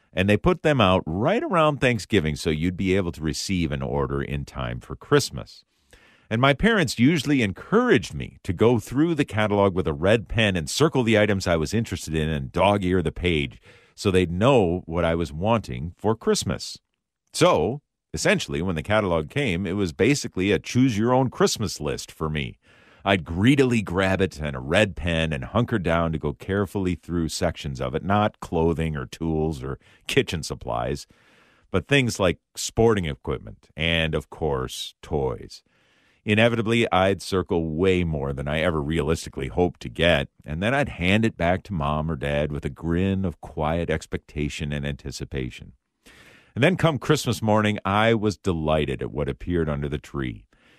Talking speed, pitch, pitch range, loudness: 180 wpm, 90 Hz, 80-110 Hz, -23 LUFS